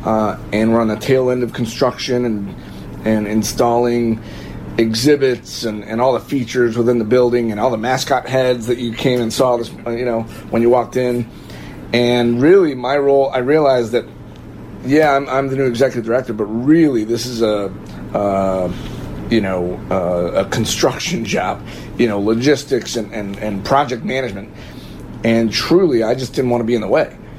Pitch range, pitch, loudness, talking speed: 110-125 Hz, 120 Hz, -16 LUFS, 180 wpm